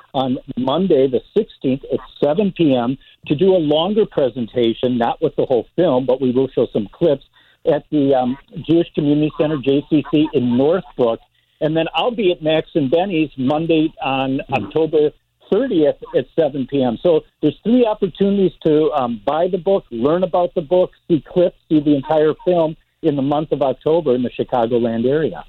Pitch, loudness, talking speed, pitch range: 155 Hz, -18 LUFS, 175 wpm, 135-170 Hz